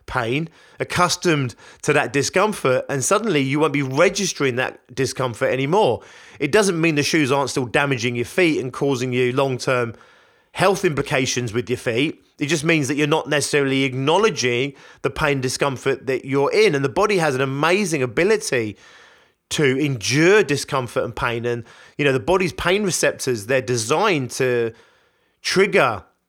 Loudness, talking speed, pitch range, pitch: -20 LUFS, 165 wpm, 130-170 Hz, 140 Hz